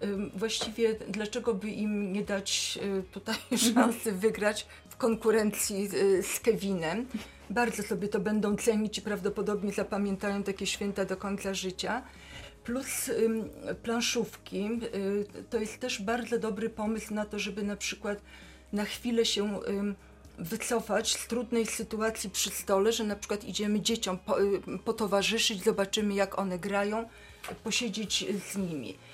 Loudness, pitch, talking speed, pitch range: -31 LUFS, 210 Hz, 125 wpm, 200-225 Hz